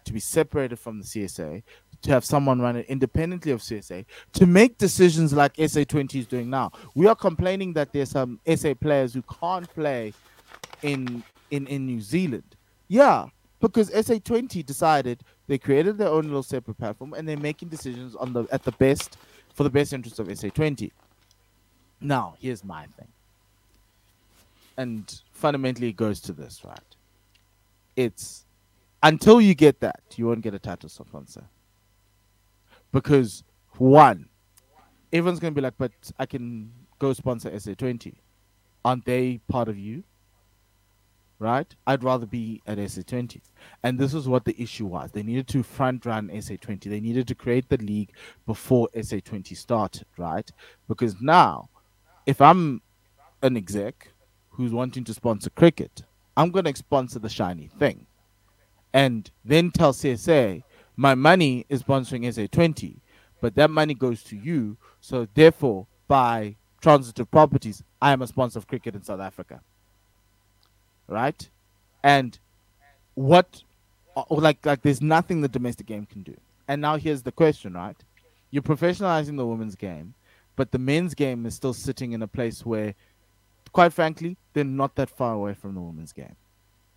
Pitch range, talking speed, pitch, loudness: 100-140 Hz, 160 wpm, 120 Hz, -23 LUFS